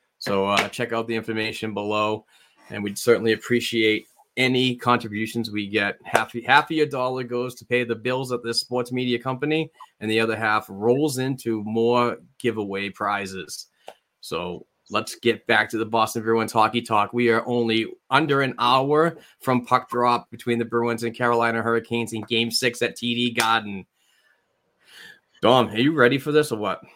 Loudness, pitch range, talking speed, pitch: -23 LUFS, 110-125 Hz, 175 wpm, 115 Hz